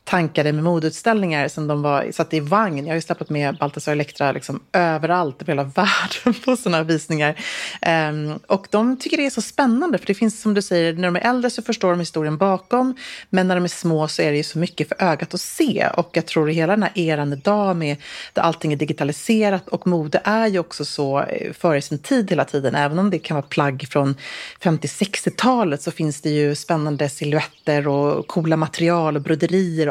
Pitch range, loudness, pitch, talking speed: 150-195 Hz, -20 LUFS, 165 Hz, 215 wpm